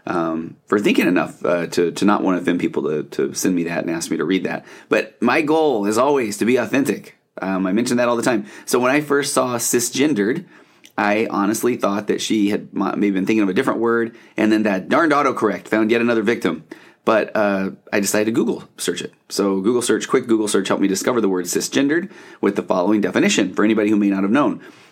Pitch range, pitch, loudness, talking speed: 100-115 Hz, 110 Hz, -19 LUFS, 235 wpm